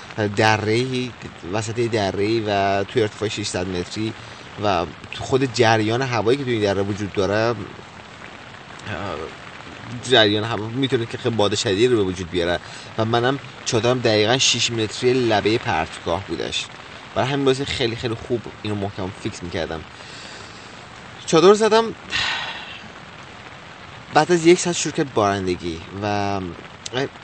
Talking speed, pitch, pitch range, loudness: 130 wpm, 110 Hz, 100-125 Hz, -21 LUFS